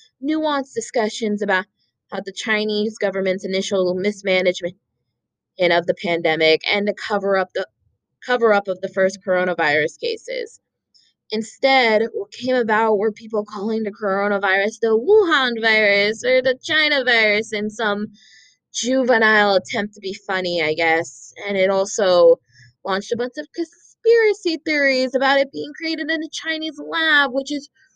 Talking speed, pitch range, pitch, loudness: 150 wpm, 190-265 Hz, 215 Hz, -19 LUFS